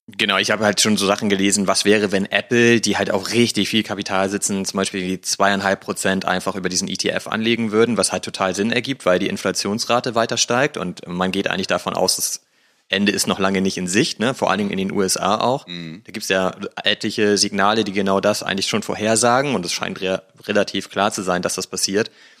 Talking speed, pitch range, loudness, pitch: 230 wpm, 95-110 Hz, -19 LUFS, 100 Hz